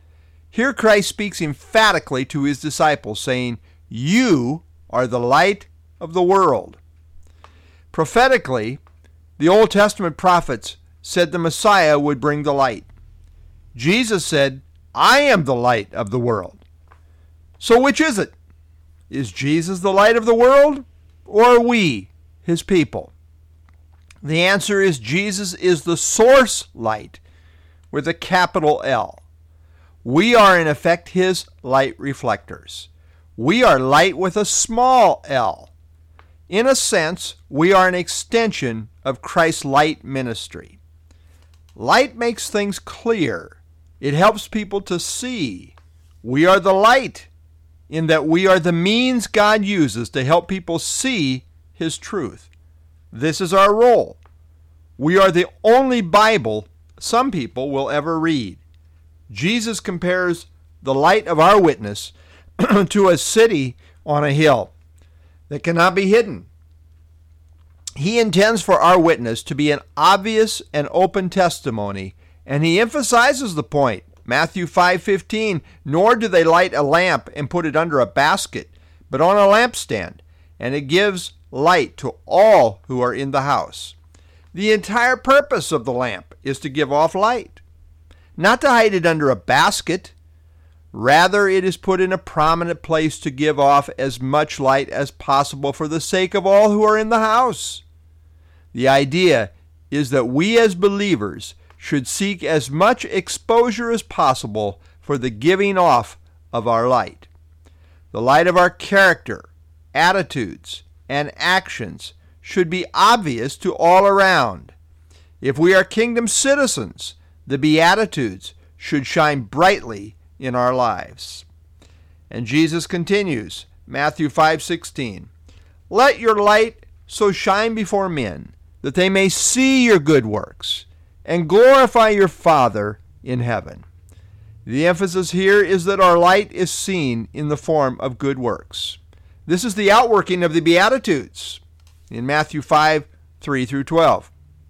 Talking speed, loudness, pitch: 140 wpm, -17 LUFS, 140 Hz